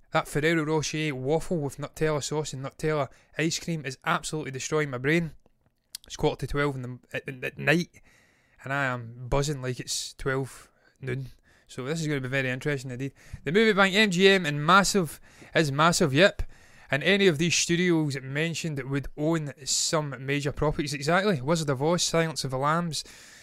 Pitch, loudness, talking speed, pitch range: 150 Hz, -26 LUFS, 185 wpm, 135-165 Hz